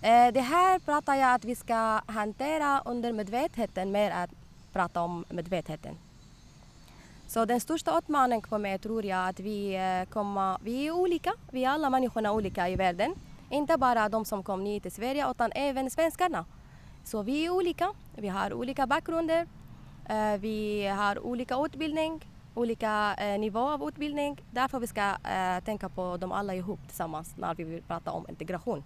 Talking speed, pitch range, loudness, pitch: 160 wpm, 200-280 Hz, -30 LUFS, 225 Hz